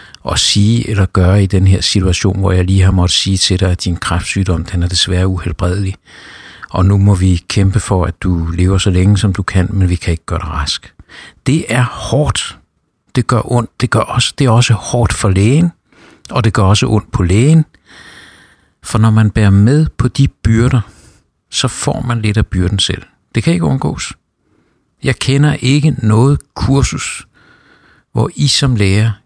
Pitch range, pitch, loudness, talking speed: 95-120 Hz, 100 Hz, -13 LUFS, 195 wpm